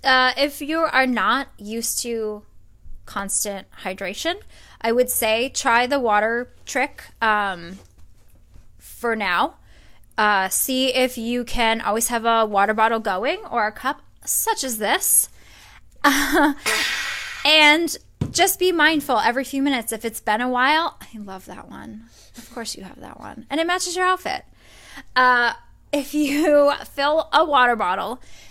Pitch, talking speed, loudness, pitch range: 235 Hz, 150 wpm, -20 LUFS, 210-285 Hz